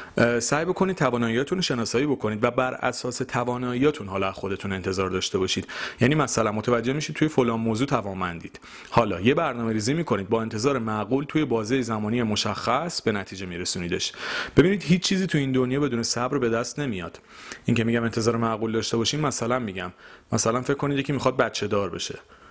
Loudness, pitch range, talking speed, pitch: -25 LUFS, 110-135 Hz, 175 wpm, 120 Hz